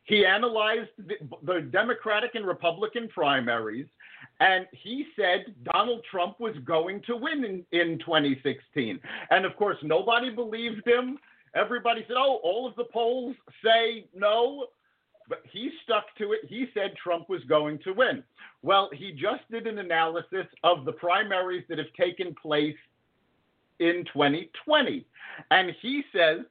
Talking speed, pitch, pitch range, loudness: 145 wpm, 200 Hz, 170-235 Hz, -27 LUFS